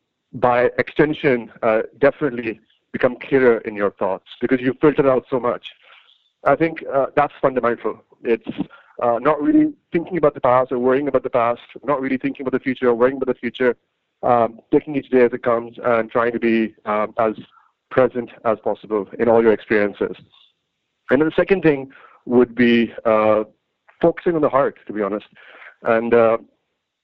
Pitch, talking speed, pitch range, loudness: 125 Hz, 180 wpm, 115-140 Hz, -19 LUFS